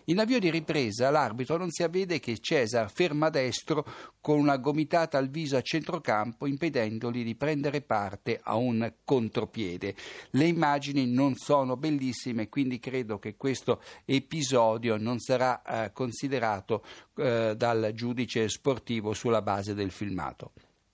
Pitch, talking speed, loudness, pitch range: 130 Hz, 140 wpm, -29 LUFS, 115-150 Hz